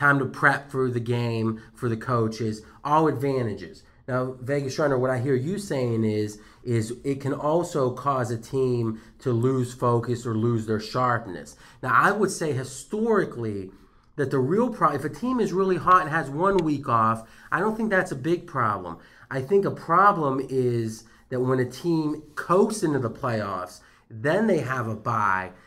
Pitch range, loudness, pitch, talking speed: 115-155 Hz, -25 LUFS, 130 Hz, 185 wpm